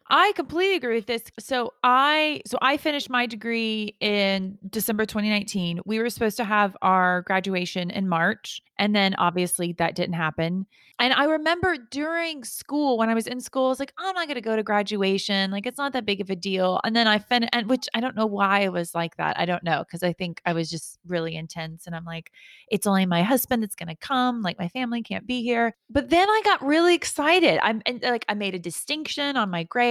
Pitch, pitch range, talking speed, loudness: 220 Hz, 185-255 Hz, 230 wpm, -24 LUFS